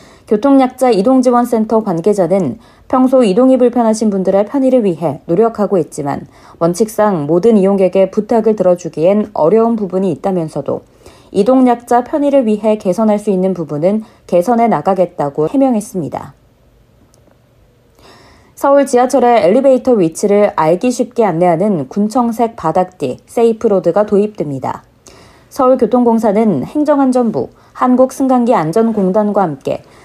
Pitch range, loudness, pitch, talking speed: 180-245 Hz, -12 LUFS, 210 Hz, 320 characters per minute